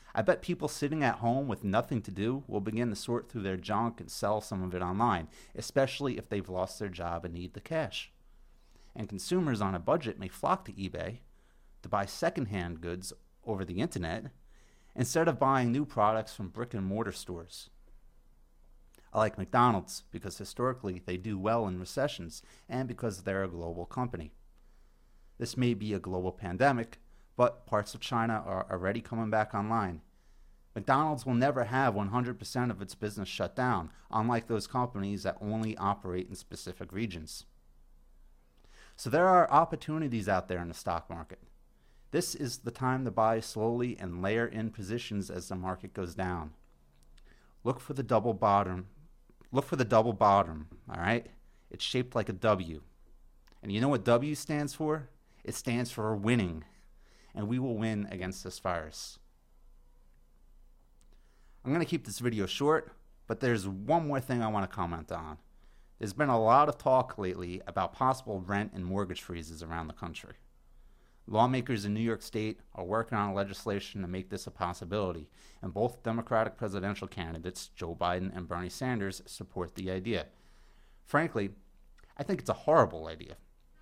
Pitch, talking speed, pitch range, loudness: 100 Hz, 170 wpm, 90-120 Hz, -32 LUFS